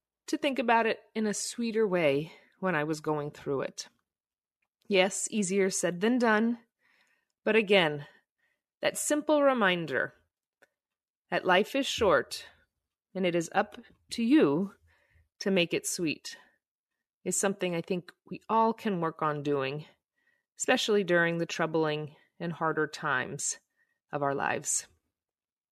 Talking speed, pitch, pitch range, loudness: 135 wpm, 195 Hz, 165-230 Hz, -29 LUFS